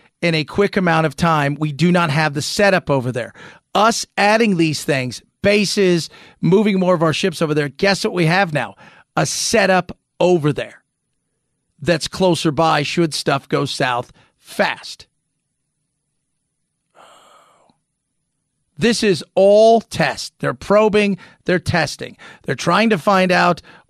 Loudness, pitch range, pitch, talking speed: -17 LUFS, 150-195 Hz, 170 Hz, 140 wpm